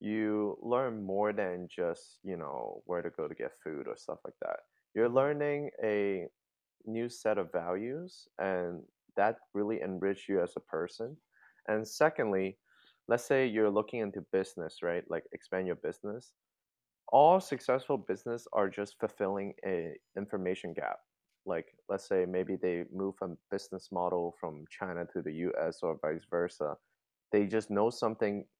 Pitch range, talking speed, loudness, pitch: 95-125 Hz, 155 wpm, -34 LUFS, 105 Hz